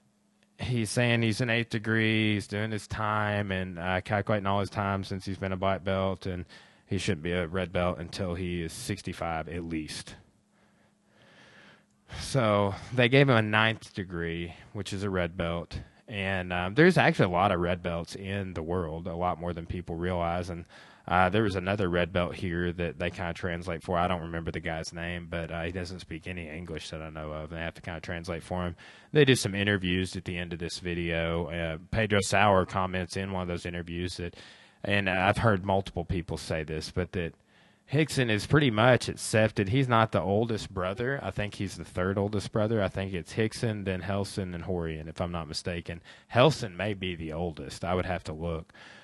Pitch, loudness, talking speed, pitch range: 95 Hz, -29 LUFS, 210 wpm, 85-105 Hz